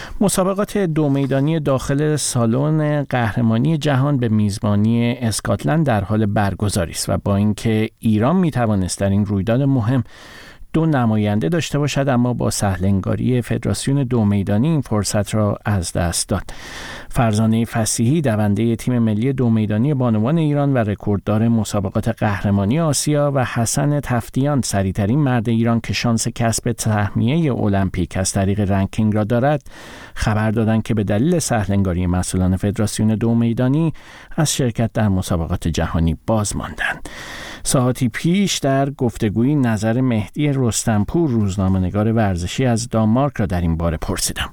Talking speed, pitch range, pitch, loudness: 140 wpm, 105-130 Hz, 115 Hz, -18 LUFS